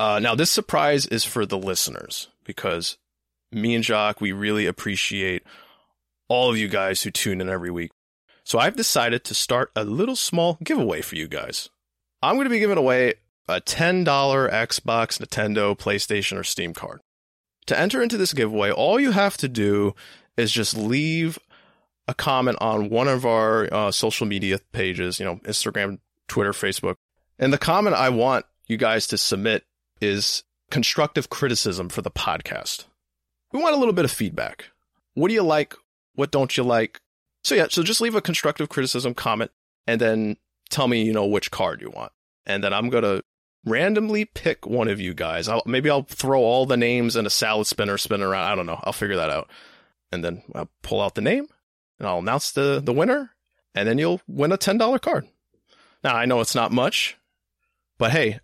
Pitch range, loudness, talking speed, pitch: 100-155 Hz, -22 LUFS, 190 wpm, 115 Hz